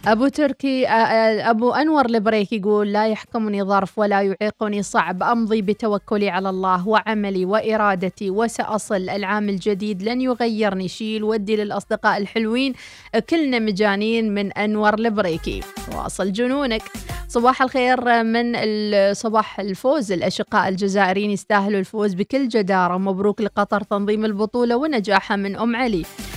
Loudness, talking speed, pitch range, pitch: -20 LUFS, 120 wpm, 200-230 Hz, 215 Hz